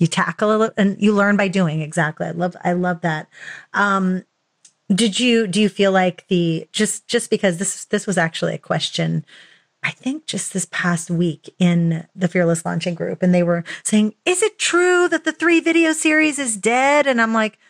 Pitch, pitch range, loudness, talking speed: 195 Hz, 175-230 Hz, -18 LUFS, 205 wpm